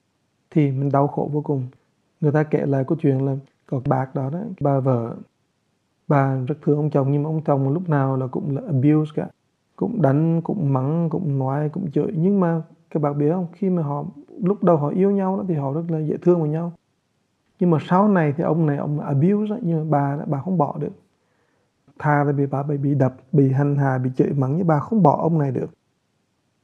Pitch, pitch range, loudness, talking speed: 150 Hz, 140-170 Hz, -21 LUFS, 235 wpm